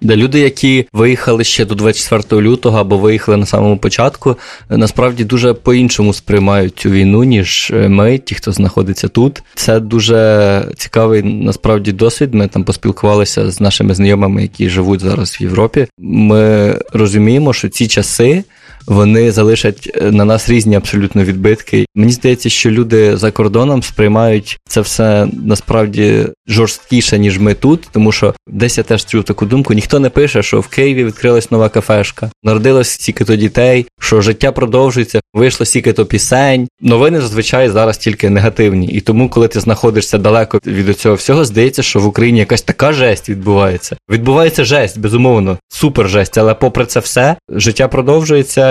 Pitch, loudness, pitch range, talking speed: 110 Hz, -10 LUFS, 105-125 Hz, 160 wpm